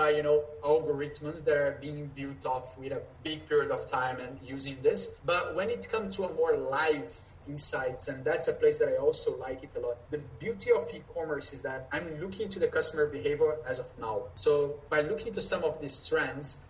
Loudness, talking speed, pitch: -30 LUFS, 220 wpm, 155 Hz